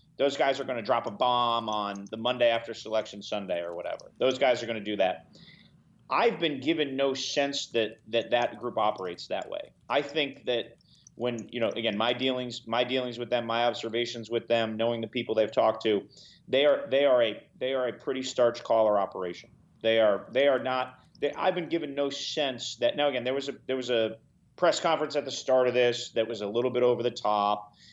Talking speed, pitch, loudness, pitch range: 225 wpm, 120 Hz, -28 LUFS, 115-130 Hz